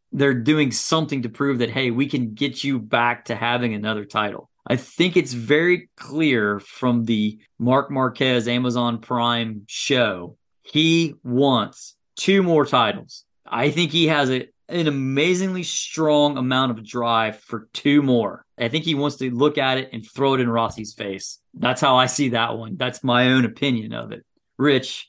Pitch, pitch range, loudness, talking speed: 130 Hz, 115-145 Hz, -21 LUFS, 175 wpm